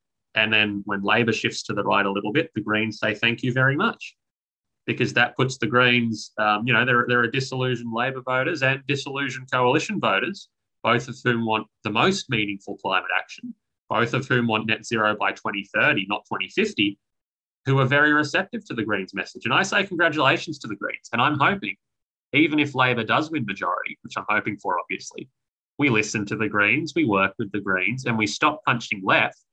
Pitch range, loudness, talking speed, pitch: 105-135 Hz, -22 LUFS, 200 wpm, 120 Hz